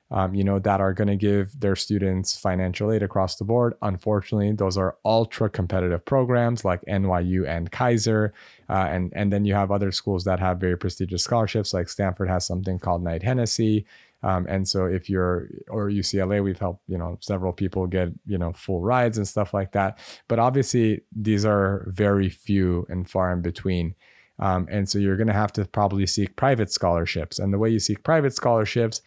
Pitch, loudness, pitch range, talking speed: 100 Hz, -24 LUFS, 95-105 Hz, 200 wpm